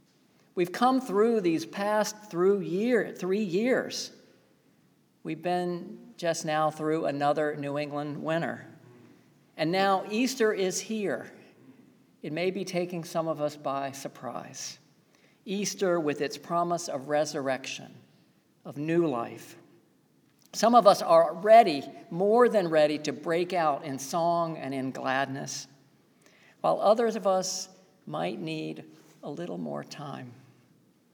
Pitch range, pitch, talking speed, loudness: 145-195 Hz, 170 Hz, 130 wpm, -28 LUFS